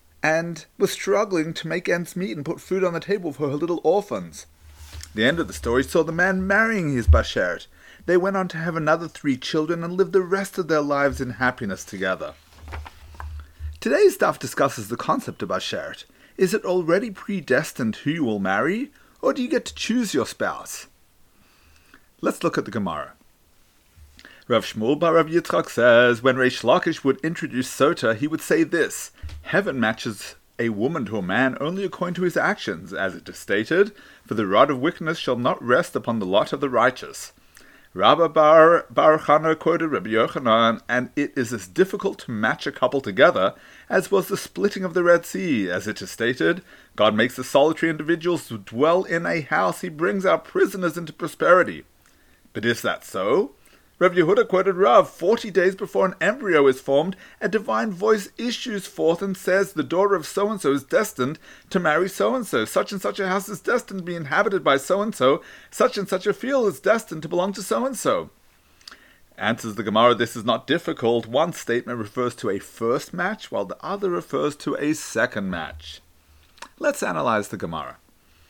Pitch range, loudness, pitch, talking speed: 125-190 Hz, -22 LUFS, 165 Hz, 190 wpm